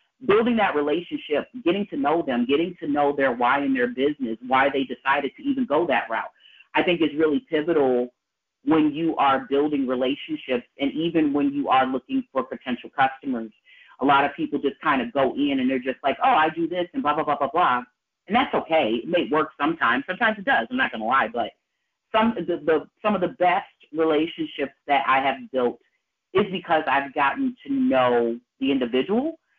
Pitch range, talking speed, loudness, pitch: 135-175 Hz, 205 wpm, -23 LUFS, 150 Hz